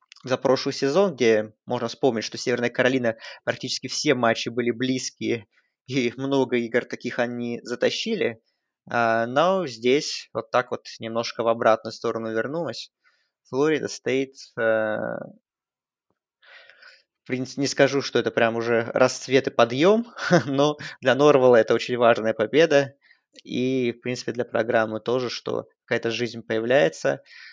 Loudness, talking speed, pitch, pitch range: -23 LUFS, 130 wpm, 125 Hz, 115-135 Hz